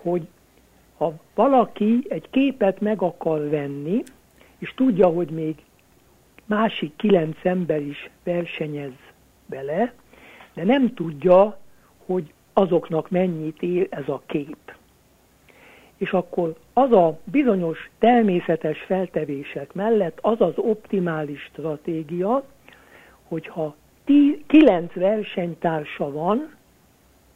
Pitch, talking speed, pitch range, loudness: 180 Hz, 100 wpm, 160-215 Hz, -22 LUFS